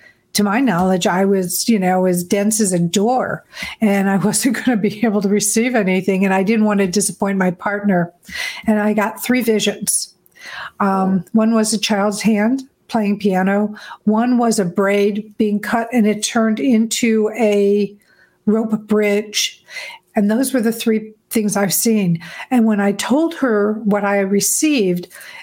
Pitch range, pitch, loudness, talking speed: 200-225 Hz, 210 Hz, -17 LUFS, 170 wpm